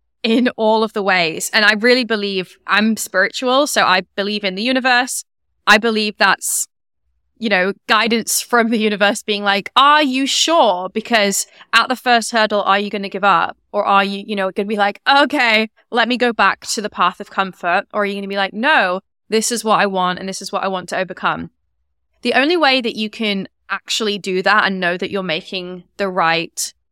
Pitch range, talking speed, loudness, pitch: 195-230 Hz, 220 wpm, -16 LUFS, 205 Hz